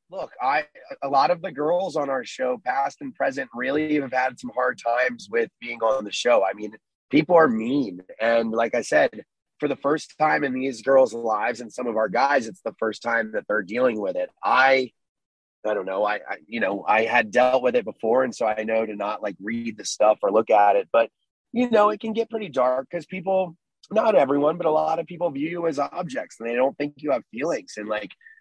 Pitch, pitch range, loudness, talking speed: 140 Hz, 115-195 Hz, -23 LUFS, 240 wpm